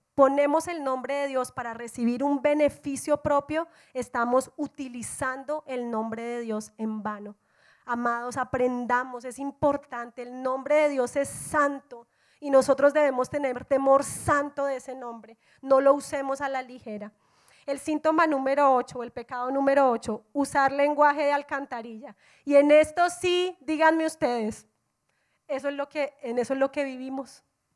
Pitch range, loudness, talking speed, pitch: 245-285 Hz, -26 LUFS, 155 wpm, 270 Hz